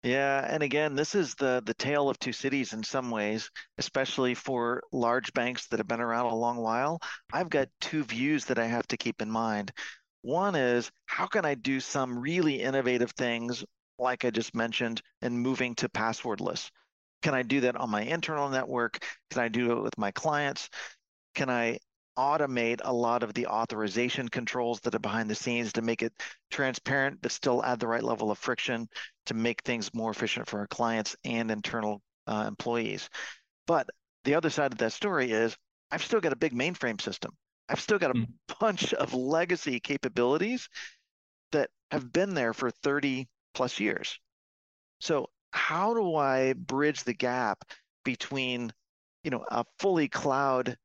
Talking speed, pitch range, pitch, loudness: 180 wpm, 115-135 Hz, 125 Hz, -30 LUFS